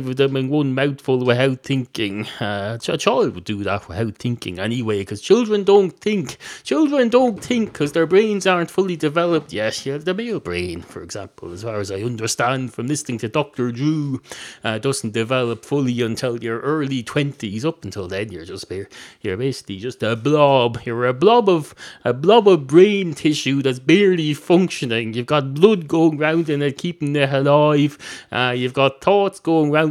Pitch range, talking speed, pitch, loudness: 120-165 Hz, 185 wpm, 135 Hz, -19 LUFS